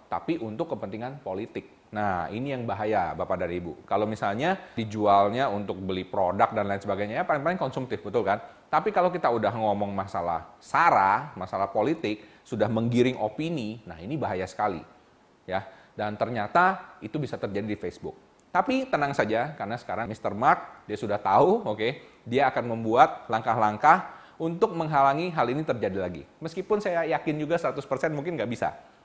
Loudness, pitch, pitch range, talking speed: -27 LUFS, 115 Hz, 105-155 Hz, 165 wpm